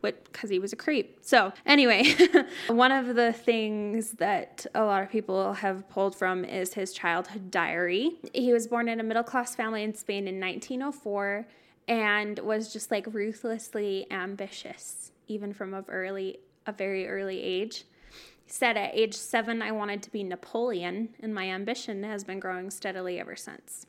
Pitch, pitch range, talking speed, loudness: 210 Hz, 195-230 Hz, 170 wpm, -28 LUFS